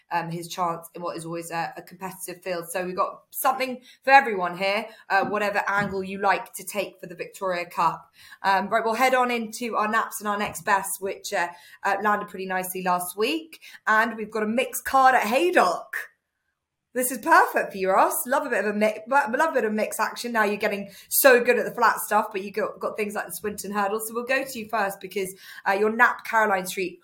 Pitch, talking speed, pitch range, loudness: 205 Hz, 235 wpm, 190-230 Hz, -24 LUFS